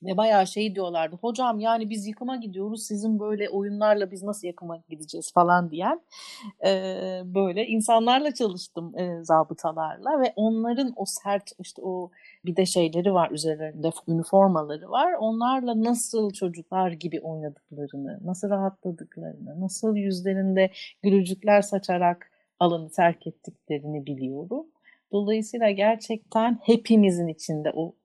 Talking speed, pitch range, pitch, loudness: 120 wpm, 170-220 Hz, 195 Hz, -25 LUFS